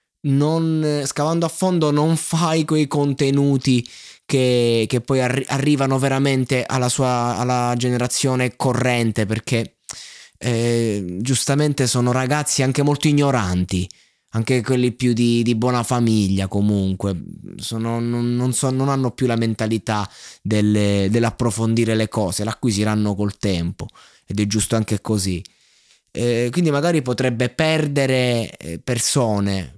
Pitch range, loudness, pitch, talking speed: 110-135 Hz, -19 LUFS, 125 Hz, 125 wpm